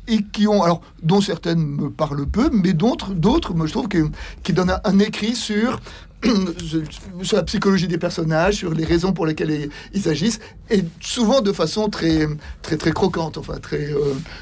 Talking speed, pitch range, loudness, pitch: 185 wpm, 160-205 Hz, -20 LUFS, 175 Hz